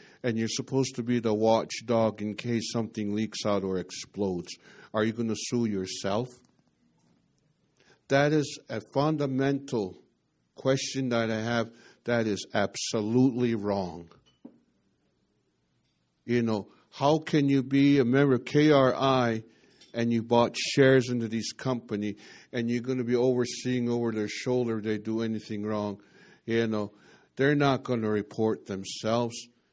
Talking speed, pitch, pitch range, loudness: 135 wpm, 115 Hz, 110-130 Hz, -28 LUFS